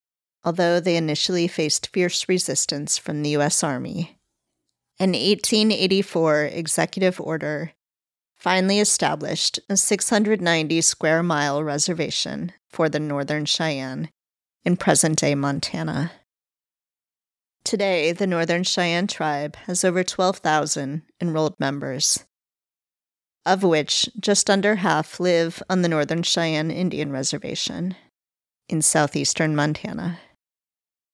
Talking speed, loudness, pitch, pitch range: 105 wpm, -21 LUFS, 165 Hz, 150-185 Hz